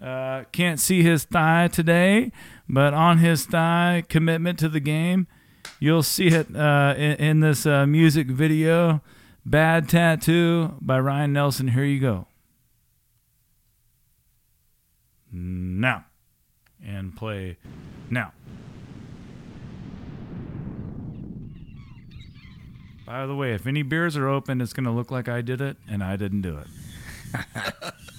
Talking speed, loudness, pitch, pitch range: 120 wpm, -22 LUFS, 145 Hz, 125-165 Hz